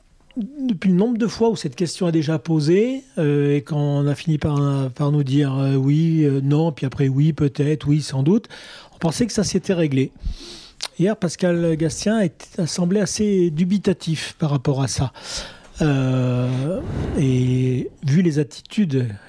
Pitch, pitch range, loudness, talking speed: 155 Hz, 140-180 Hz, -20 LUFS, 170 wpm